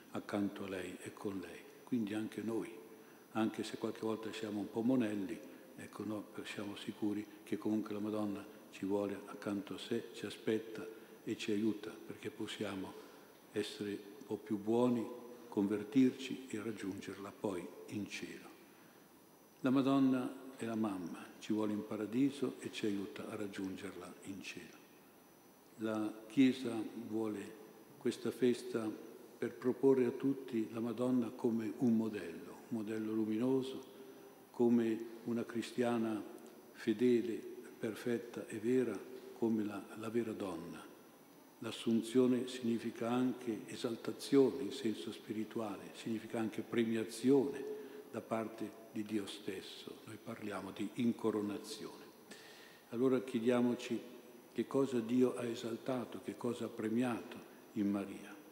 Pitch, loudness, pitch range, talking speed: 110 Hz, -39 LUFS, 105-120 Hz, 130 wpm